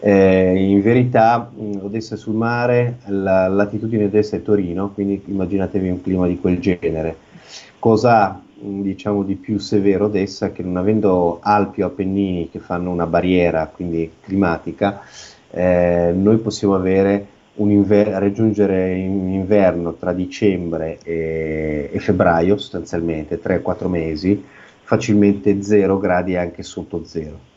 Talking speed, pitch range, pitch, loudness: 130 wpm, 90-105 Hz, 95 Hz, -18 LUFS